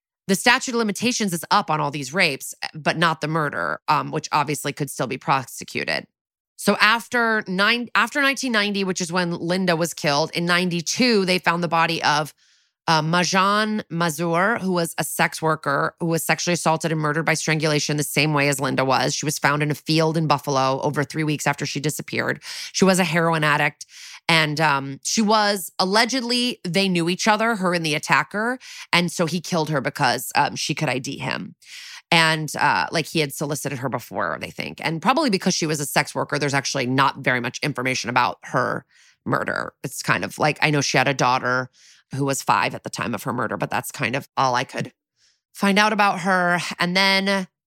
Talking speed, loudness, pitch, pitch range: 205 wpm, -21 LUFS, 160 Hz, 145-185 Hz